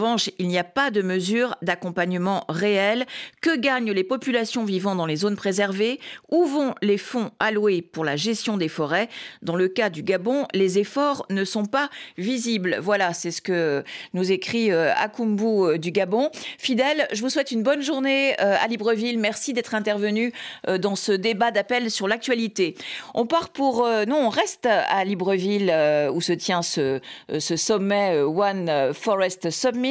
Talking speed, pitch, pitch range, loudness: 170 wpm, 210 Hz, 185-245 Hz, -23 LUFS